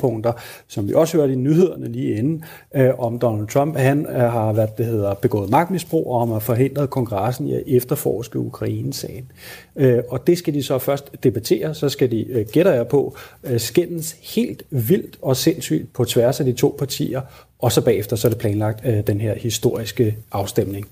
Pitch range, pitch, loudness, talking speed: 115-145 Hz, 125 Hz, -20 LUFS, 180 wpm